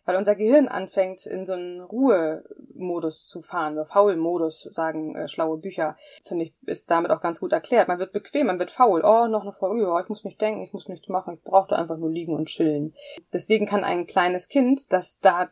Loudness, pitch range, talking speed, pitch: -23 LUFS, 170-205 Hz, 215 wpm, 185 Hz